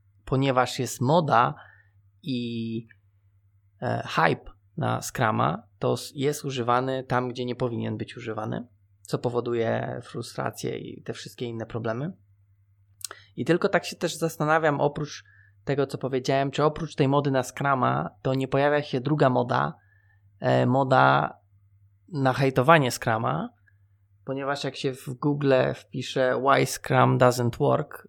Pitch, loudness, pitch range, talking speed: 125 Hz, -25 LUFS, 100-140 Hz, 130 wpm